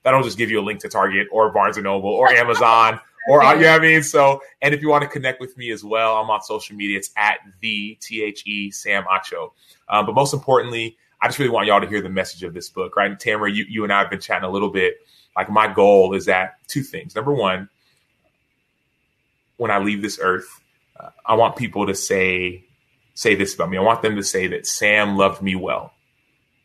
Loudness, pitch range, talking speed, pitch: -18 LUFS, 100-135 Hz, 240 wpm, 110 Hz